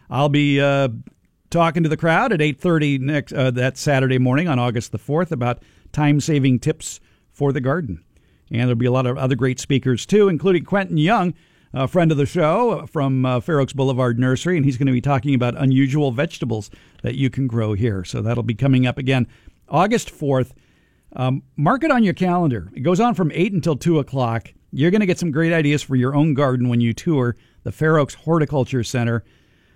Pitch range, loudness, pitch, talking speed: 125-160 Hz, -19 LUFS, 135 Hz, 210 wpm